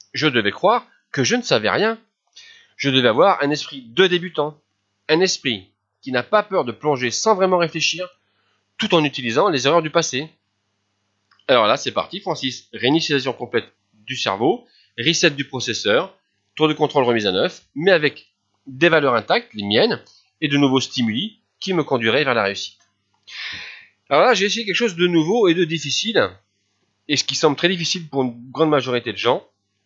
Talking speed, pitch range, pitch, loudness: 185 wpm, 115-175 Hz, 145 Hz, -19 LUFS